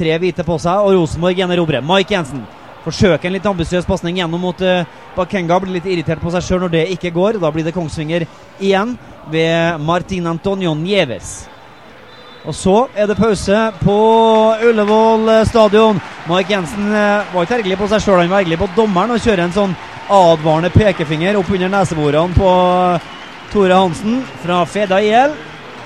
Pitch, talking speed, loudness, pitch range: 185 Hz, 165 wpm, -14 LUFS, 170-205 Hz